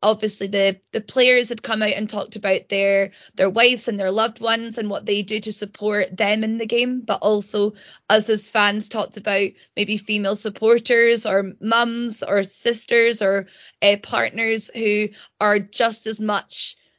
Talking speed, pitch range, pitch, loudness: 175 wpm, 200-225 Hz, 210 Hz, -20 LUFS